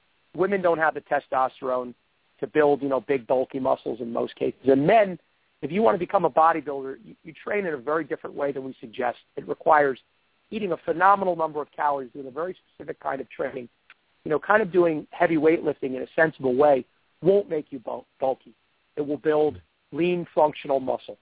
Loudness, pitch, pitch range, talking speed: -24 LUFS, 150 Hz, 135-165 Hz, 200 wpm